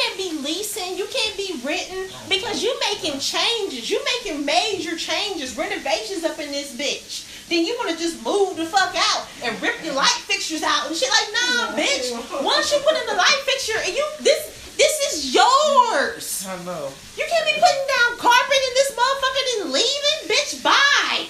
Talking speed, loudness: 190 wpm, -20 LUFS